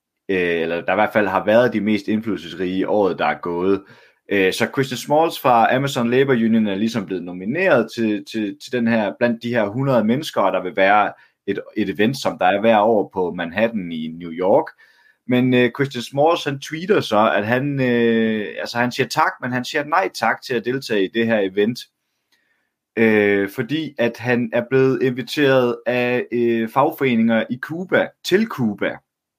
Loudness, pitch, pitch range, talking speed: -19 LUFS, 120 Hz, 105-130 Hz, 180 wpm